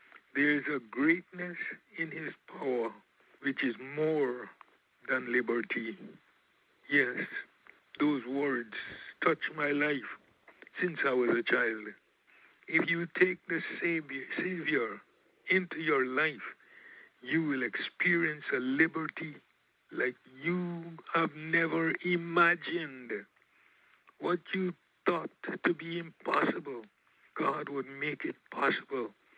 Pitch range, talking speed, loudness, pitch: 145-175 Hz, 105 wpm, -32 LUFS, 165 Hz